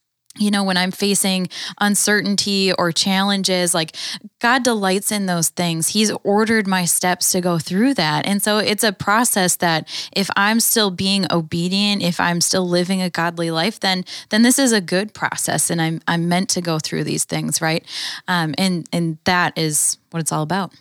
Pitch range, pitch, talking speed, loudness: 170-205 Hz, 185 Hz, 190 wpm, -18 LUFS